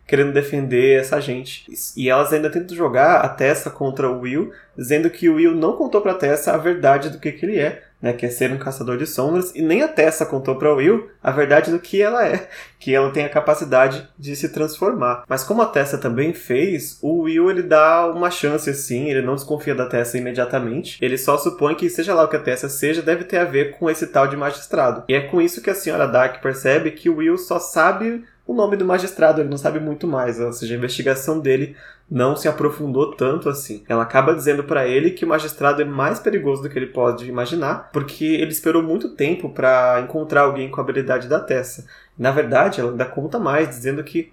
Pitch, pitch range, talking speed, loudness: 145 Hz, 130-165 Hz, 230 wpm, -19 LUFS